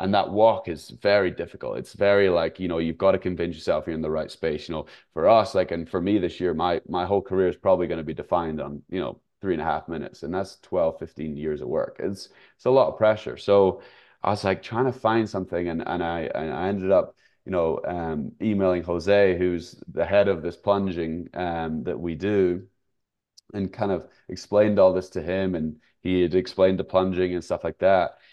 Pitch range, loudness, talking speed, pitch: 85-100 Hz, -24 LUFS, 235 wpm, 95 Hz